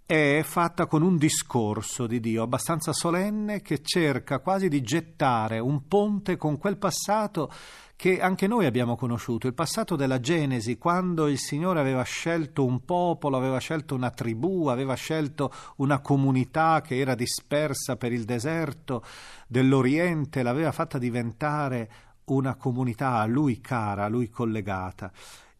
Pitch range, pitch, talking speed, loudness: 125-165 Hz, 140 Hz, 145 wpm, -26 LUFS